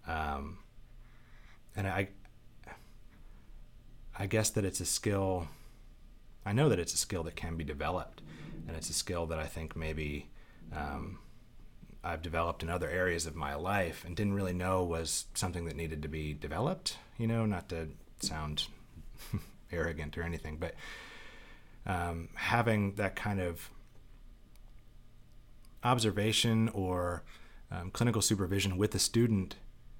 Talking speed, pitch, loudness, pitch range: 140 wpm, 95 Hz, -34 LUFS, 80-110 Hz